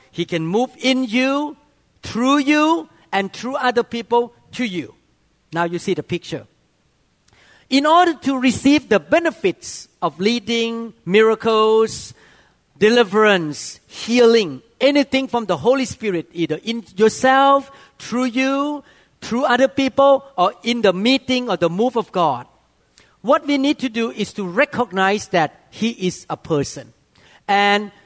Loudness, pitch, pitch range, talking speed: -18 LUFS, 235 Hz, 195-265 Hz, 140 wpm